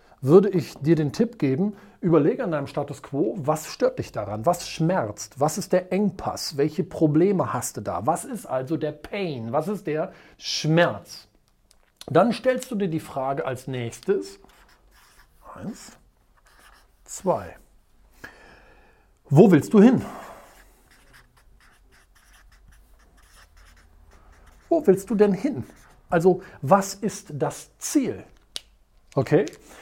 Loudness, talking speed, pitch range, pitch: -23 LUFS, 120 wpm, 130-190 Hz, 155 Hz